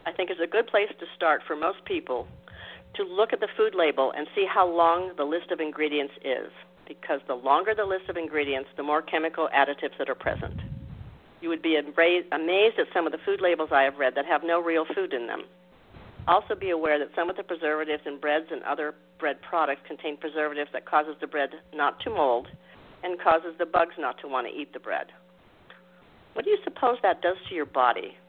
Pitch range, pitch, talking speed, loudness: 150-190 Hz, 165 Hz, 220 wpm, -27 LUFS